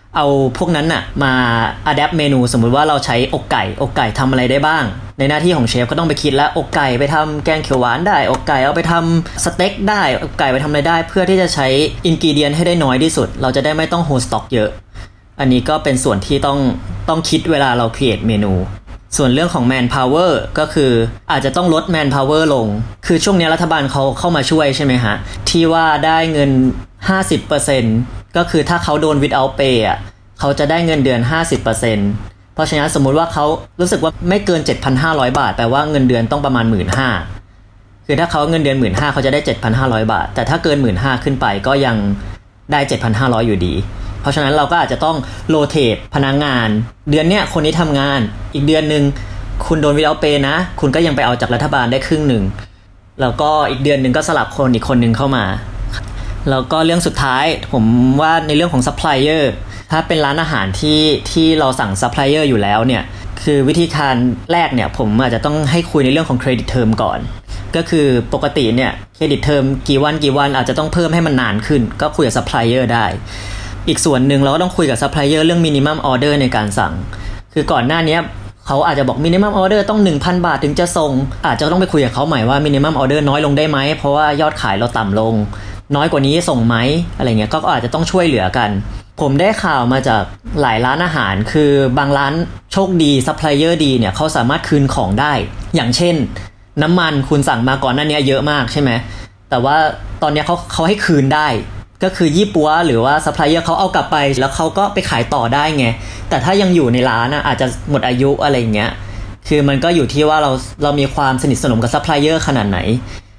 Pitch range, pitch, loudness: 115-155 Hz, 140 Hz, -14 LUFS